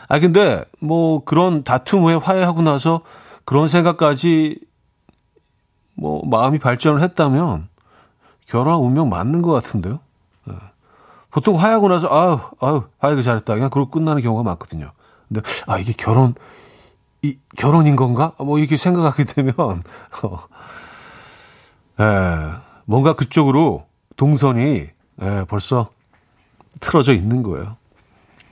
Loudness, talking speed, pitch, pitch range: -17 LUFS, 255 characters per minute, 140 Hz, 110-160 Hz